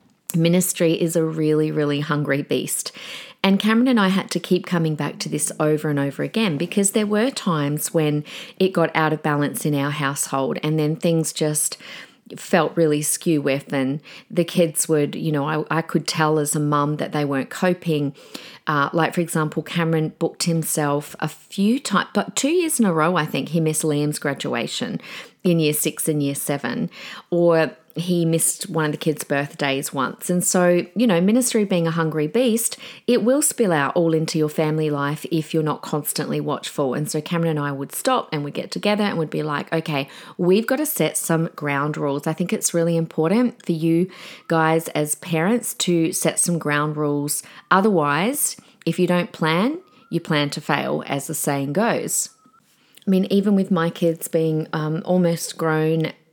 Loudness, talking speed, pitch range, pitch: -21 LUFS, 195 wpm, 150-180 Hz, 160 Hz